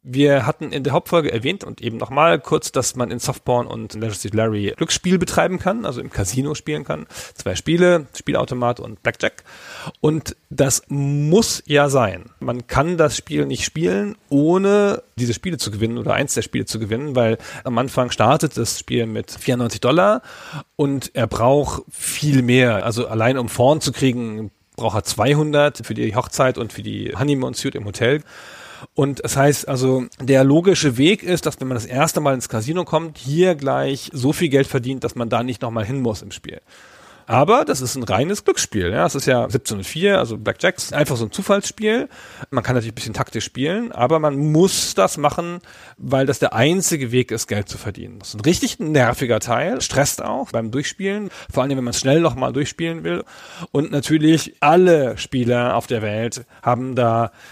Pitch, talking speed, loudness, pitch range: 135 Hz, 195 wpm, -19 LUFS, 120-155 Hz